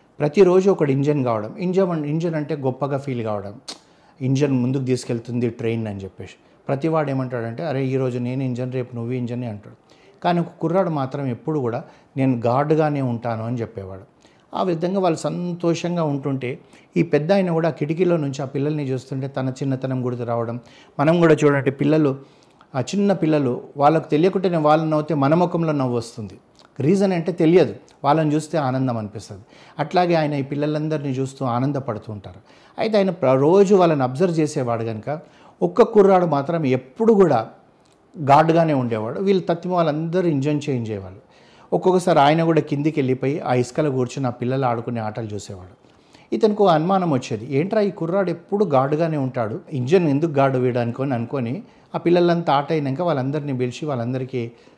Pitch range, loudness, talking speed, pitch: 125-165 Hz, -20 LUFS, 155 wpm, 140 Hz